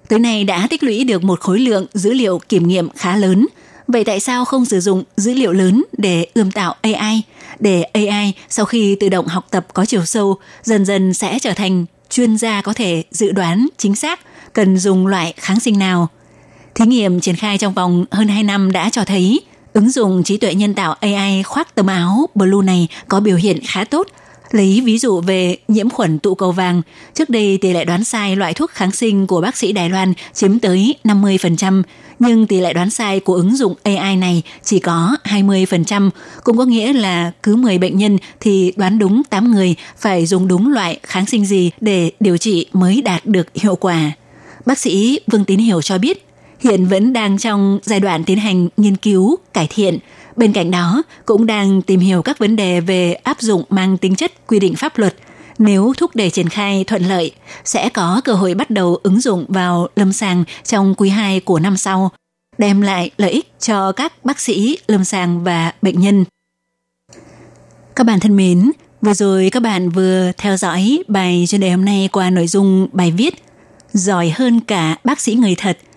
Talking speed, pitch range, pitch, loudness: 205 wpm, 185-220 Hz, 195 Hz, -14 LUFS